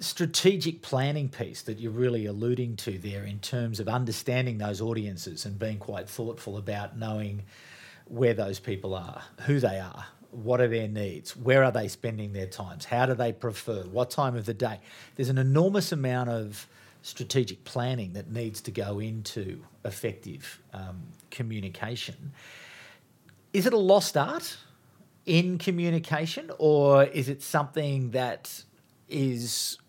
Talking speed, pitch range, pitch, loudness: 150 wpm, 110-140 Hz, 120 Hz, -29 LUFS